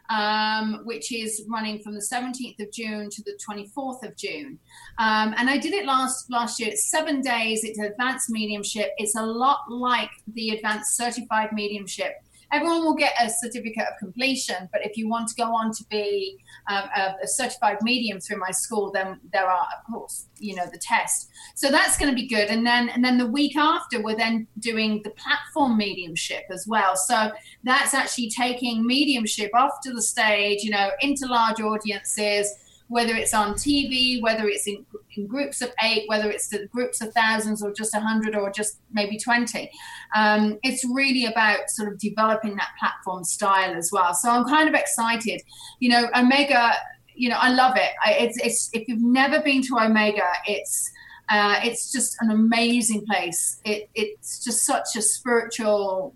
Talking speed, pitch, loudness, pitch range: 190 wpm, 225 Hz, -23 LUFS, 210-250 Hz